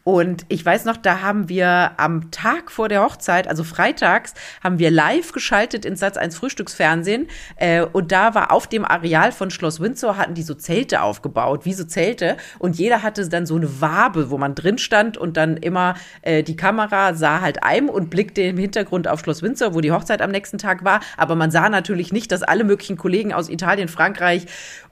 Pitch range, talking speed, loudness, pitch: 165-205 Hz, 200 wpm, -19 LUFS, 185 Hz